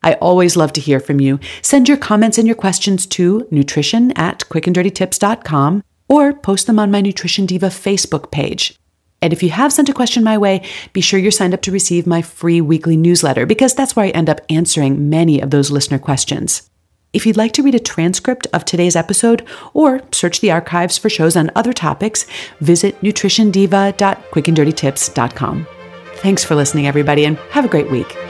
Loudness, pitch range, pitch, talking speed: -14 LUFS, 155-210 Hz, 180 Hz, 185 wpm